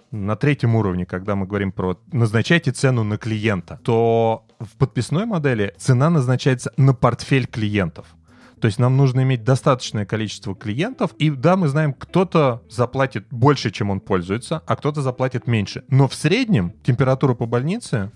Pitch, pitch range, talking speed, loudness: 125 Hz, 110-140 Hz, 160 wpm, -20 LUFS